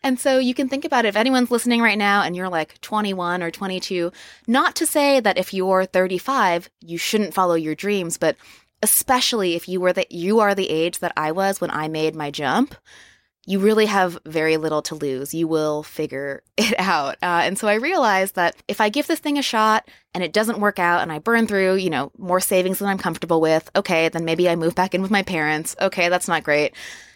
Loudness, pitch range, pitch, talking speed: -20 LUFS, 170-215 Hz, 185 Hz, 230 wpm